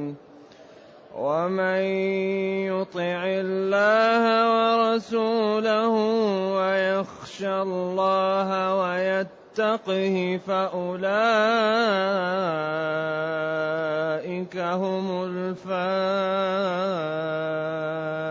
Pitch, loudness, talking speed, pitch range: 190 Hz, -24 LUFS, 35 wpm, 180-195 Hz